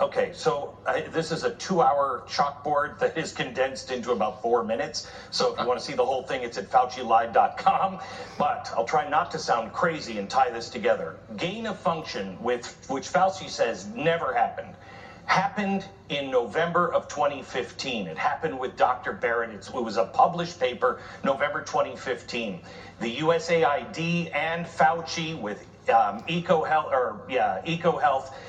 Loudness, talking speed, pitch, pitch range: -26 LUFS, 160 wpm, 165 Hz, 145-185 Hz